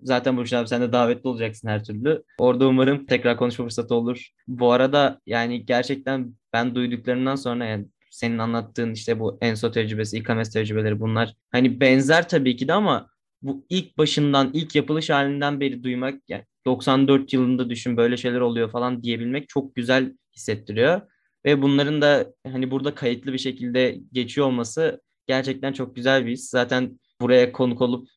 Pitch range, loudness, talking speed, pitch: 120-135 Hz, -22 LUFS, 165 wpm, 125 Hz